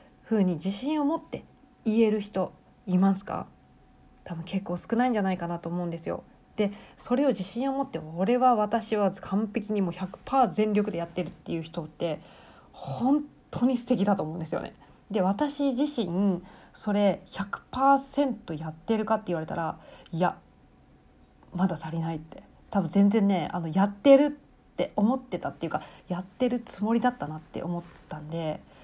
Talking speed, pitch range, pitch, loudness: 320 characters per minute, 175-235 Hz, 200 Hz, -28 LUFS